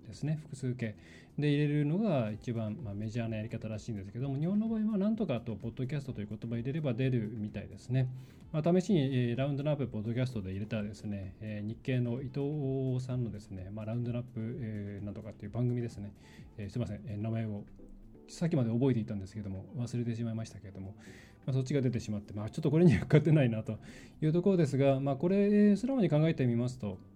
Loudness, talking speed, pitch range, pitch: -33 LUFS, 465 characters per minute, 105-140 Hz, 120 Hz